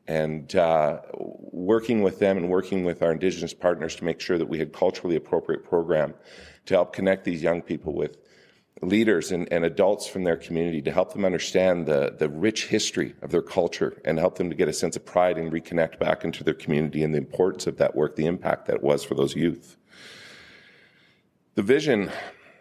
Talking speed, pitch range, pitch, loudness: 200 wpm, 80-95 Hz, 85 Hz, -25 LUFS